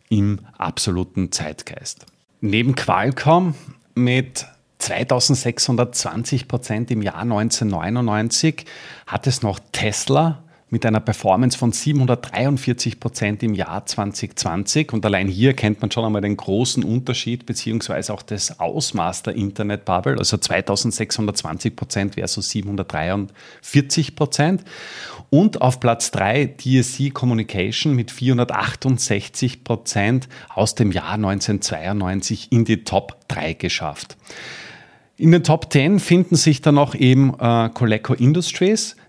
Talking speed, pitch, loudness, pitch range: 115 wpm, 120 Hz, -19 LUFS, 105-135 Hz